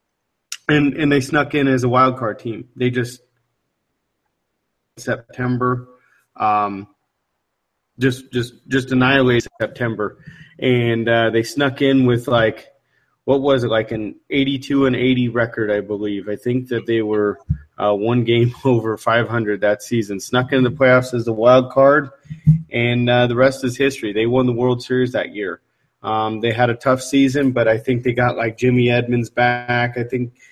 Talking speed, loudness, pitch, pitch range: 175 wpm, -18 LUFS, 125 Hz, 115-130 Hz